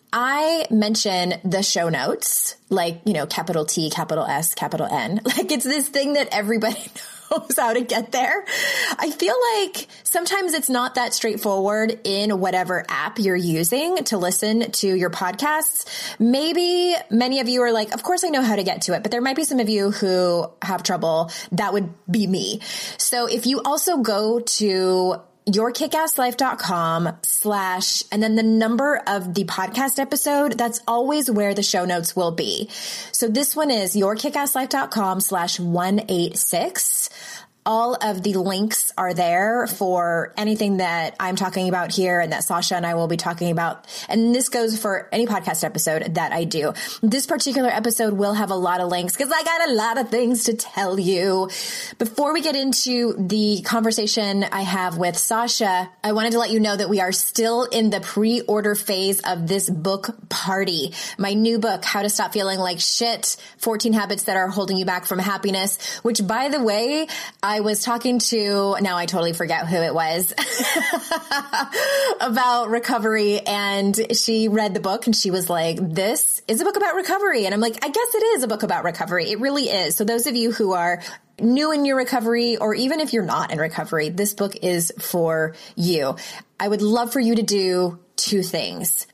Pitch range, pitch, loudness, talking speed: 185-245 Hz, 215 Hz, -21 LUFS, 190 wpm